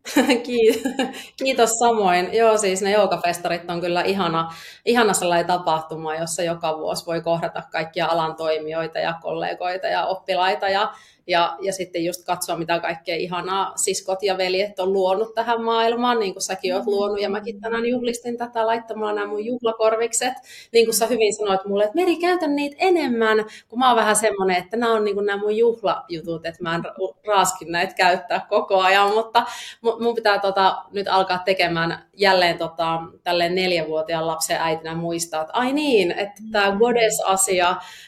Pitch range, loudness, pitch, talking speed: 175-230 Hz, -21 LUFS, 195 Hz, 165 wpm